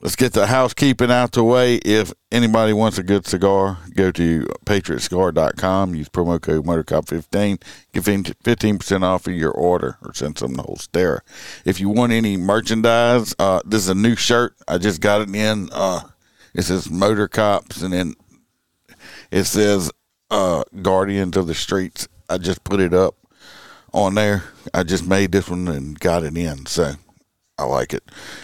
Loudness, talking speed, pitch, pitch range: -19 LUFS, 170 wpm, 95 Hz, 90-105 Hz